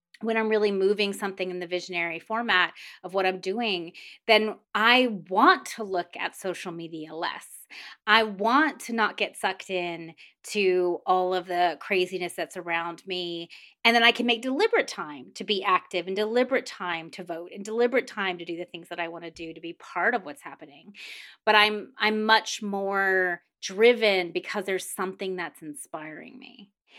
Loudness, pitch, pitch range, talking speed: -25 LUFS, 190 Hz, 175-220 Hz, 180 wpm